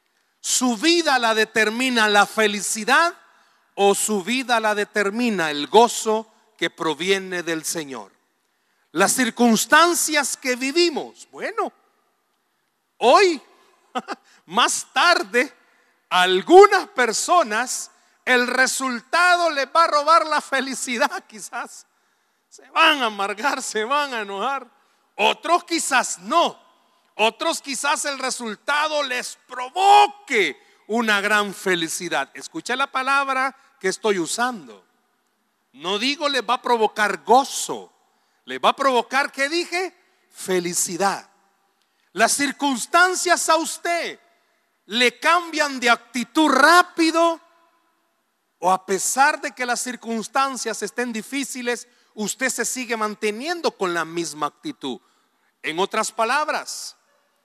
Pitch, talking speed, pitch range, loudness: 255 Hz, 110 wpm, 215-330 Hz, -20 LUFS